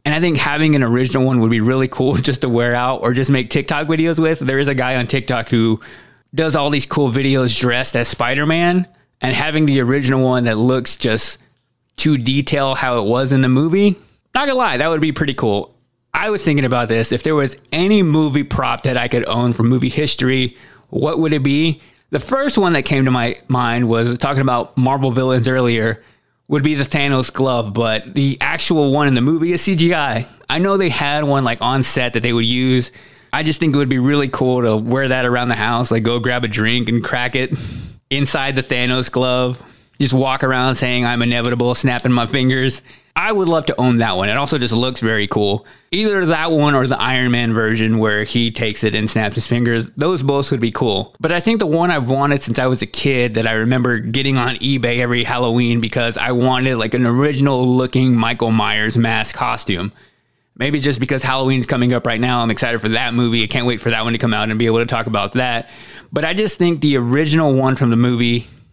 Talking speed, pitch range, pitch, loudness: 230 wpm, 120-140 Hz, 130 Hz, -16 LUFS